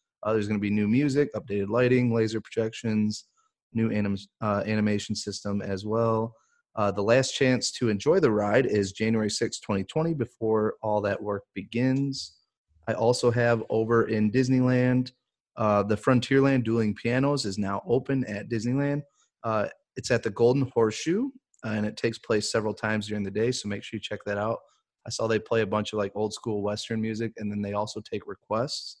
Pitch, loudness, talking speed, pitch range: 110 Hz, -27 LUFS, 190 wpm, 105-125 Hz